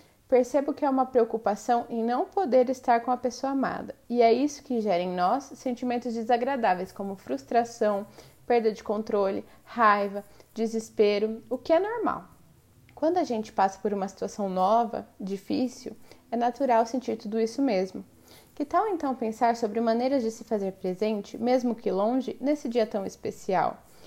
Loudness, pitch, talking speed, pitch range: -27 LUFS, 235 Hz, 160 wpm, 215-255 Hz